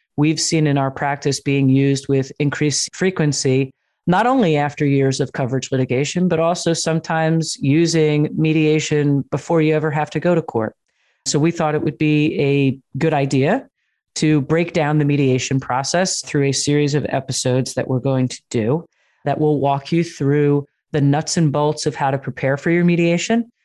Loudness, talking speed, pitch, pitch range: -18 LUFS, 180 wpm, 150 Hz, 135-160 Hz